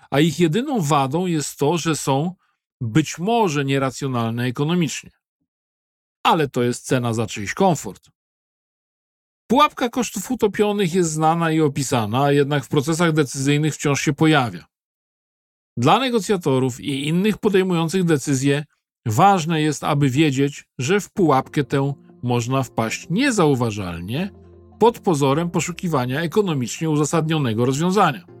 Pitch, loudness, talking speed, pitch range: 155 Hz, -20 LUFS, 120 wpm, 135-180 Hz